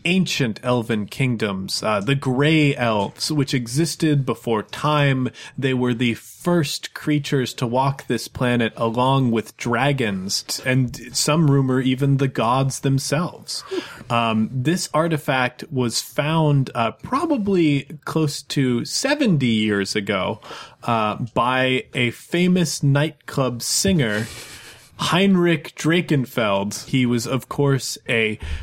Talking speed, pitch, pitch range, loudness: 115 wpm, 135 Hz, 120-150 Hz, -21 LUFS